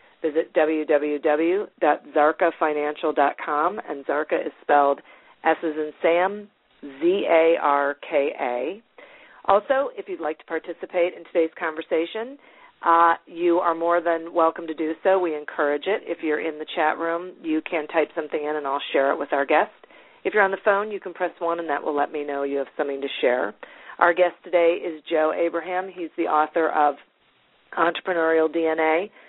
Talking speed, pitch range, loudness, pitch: 170 wpm, 155-180 Hz, -23 LUFS, 165 Hz